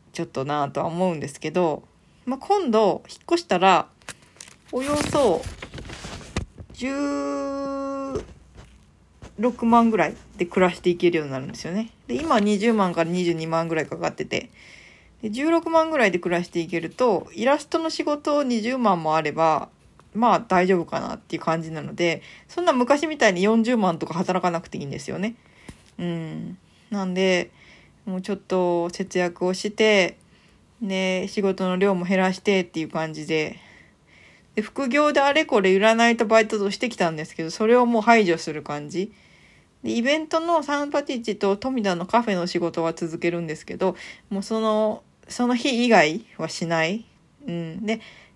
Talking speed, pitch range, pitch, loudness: 310 characters per minute, 170-240 Hz, 195 Hz, -23 LUFS